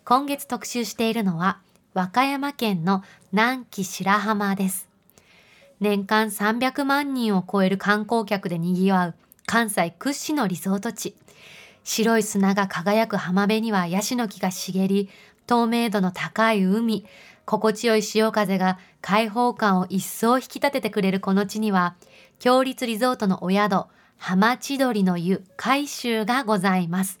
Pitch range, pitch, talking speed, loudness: 190-235 Hz, 210 Hz, 260 characters per minute, -23 LUFS